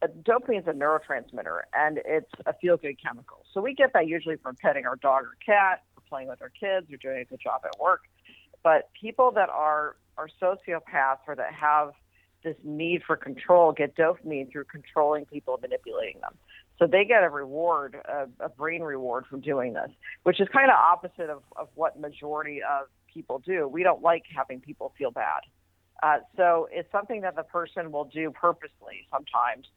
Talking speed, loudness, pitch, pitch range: 190 wpm, -26 LUFS, 155 Hz, 145-180 Hz